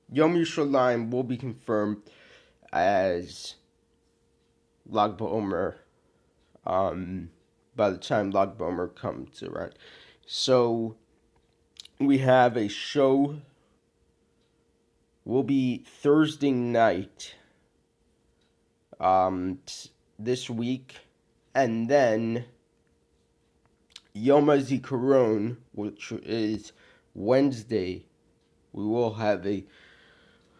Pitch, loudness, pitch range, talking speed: 120 Hz, -26 LUFS, 105-135 Hz, 75 wpm